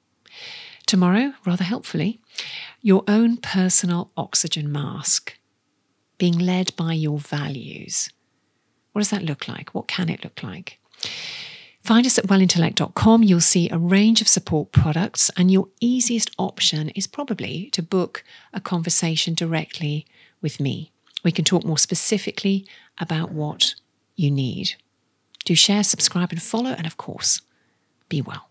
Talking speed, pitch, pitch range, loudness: 140 wpm, 180 Hz, 160-210 Hz, -20 LUFS